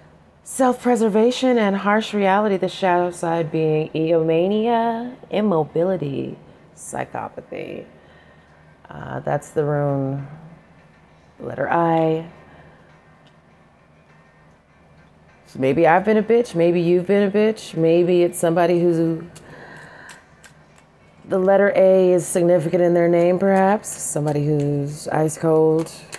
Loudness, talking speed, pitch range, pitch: -19 LUFS, 105 wpm, 155-195 Hz, 170 Hz